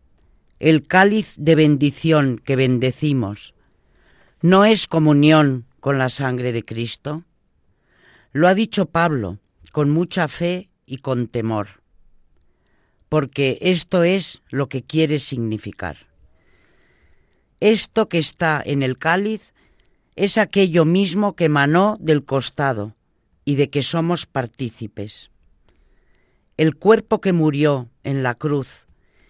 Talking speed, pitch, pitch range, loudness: 115 wpm, 140 Hz, 110-165 Hz, -19 LUFS